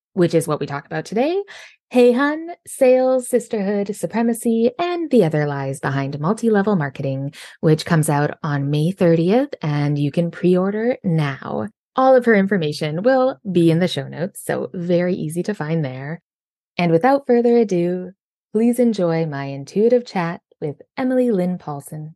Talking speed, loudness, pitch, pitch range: 165 wpm, -19 LUFS, 180 Hz, 155-235 Hz